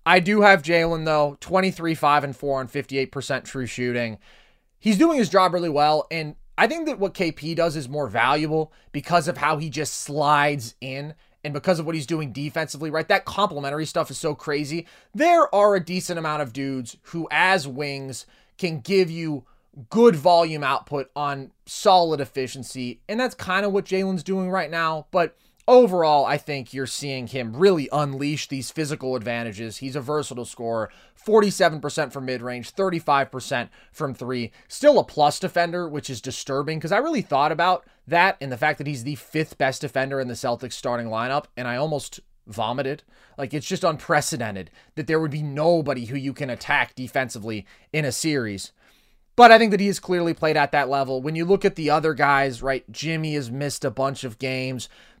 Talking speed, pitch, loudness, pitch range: 190 wpm, 150 Hz, -22 LUFS, 135-170 Hz